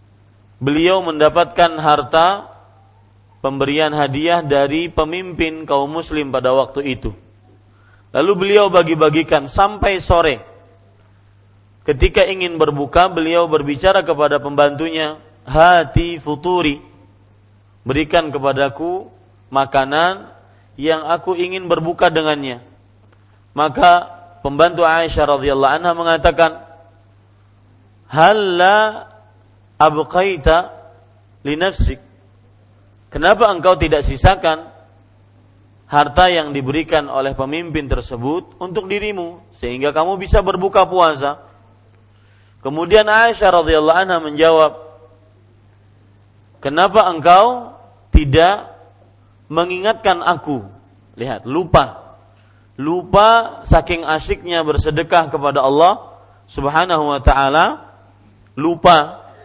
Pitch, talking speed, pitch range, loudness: 145 Hz, 80 wpm, 100-170 Hz, -15 LUFS